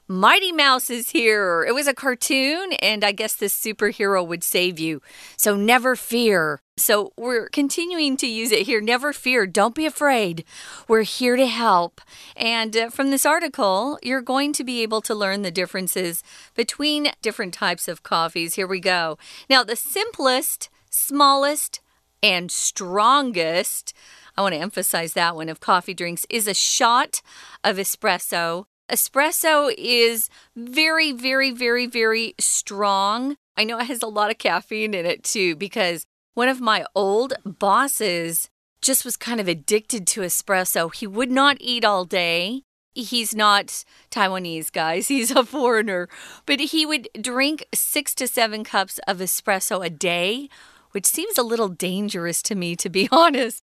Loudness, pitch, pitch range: -20 LUFS, 220 Hz, 190-265 Hz